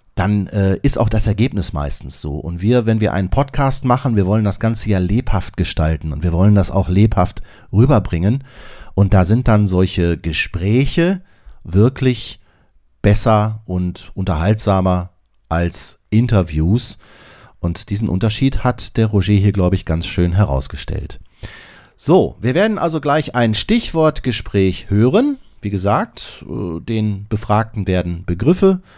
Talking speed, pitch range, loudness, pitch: 140 wpm, 90-115 Hz, -17 LUFS, 105 Hz